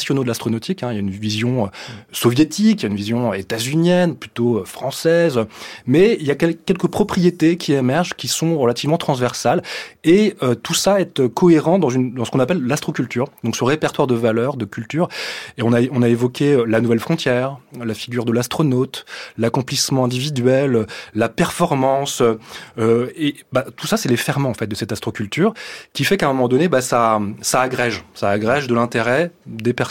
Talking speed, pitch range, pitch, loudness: 190 wpm, 115-155 Hz, 125 Hz, -18 LUFS